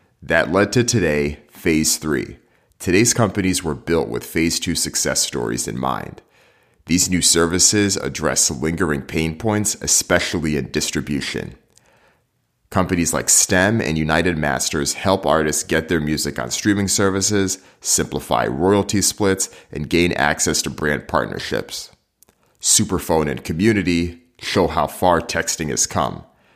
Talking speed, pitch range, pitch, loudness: 135 wpm, 80-100 Hz, 85 Hz, -18 LUFS